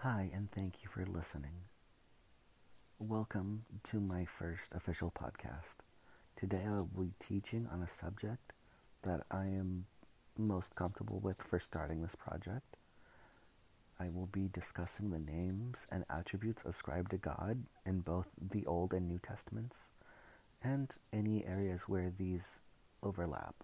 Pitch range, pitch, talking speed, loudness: 90-105 Hz, 95 Hz, 135 wpm, -43 LUFS